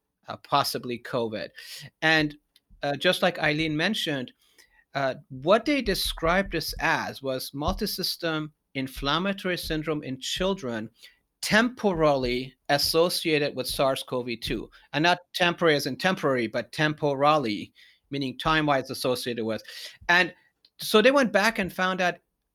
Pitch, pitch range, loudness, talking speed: 155 Hz, 135-180 Hz, -26 LUFS, 130 wpm